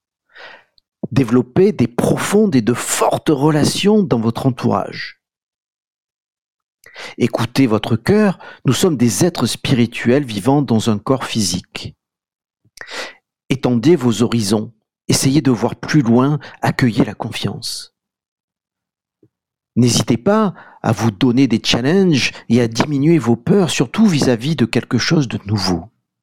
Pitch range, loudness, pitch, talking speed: 115-155 Hz, -16 LUFS, 125 Hz, 120 wpm